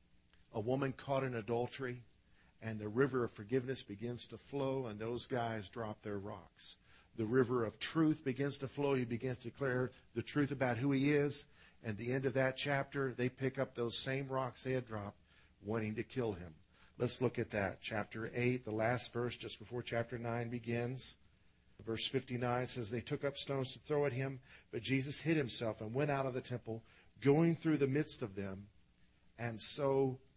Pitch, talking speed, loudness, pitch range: 125 Hz, 195 wpm, -39 LUFS, 110-135 Hz